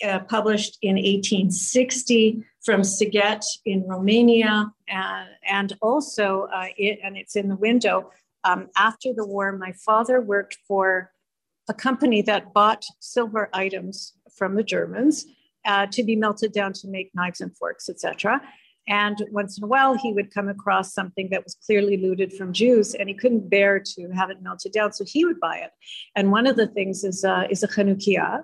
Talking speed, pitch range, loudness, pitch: 180 wpm, 195-220 Hz, -22 LUFS, 205 Hz